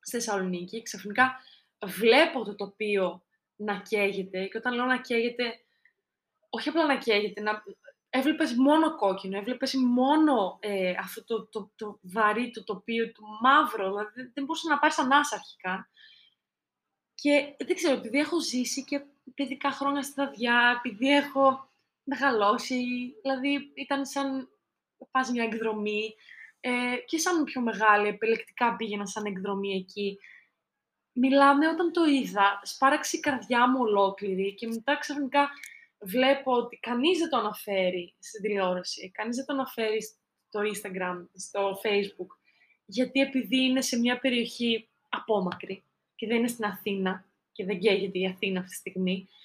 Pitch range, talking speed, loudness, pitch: 205-275 Hz, 145 wpm, -27 LUFS, 235 Hz